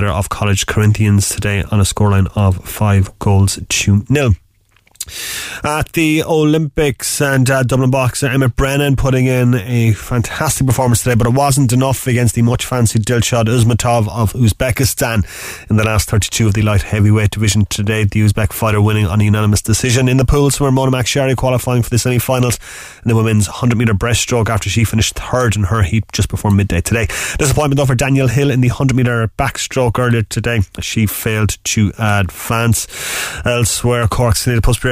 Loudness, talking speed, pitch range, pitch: -14 LUFS, 185 wpm, 105-125 Hz, 115 Hz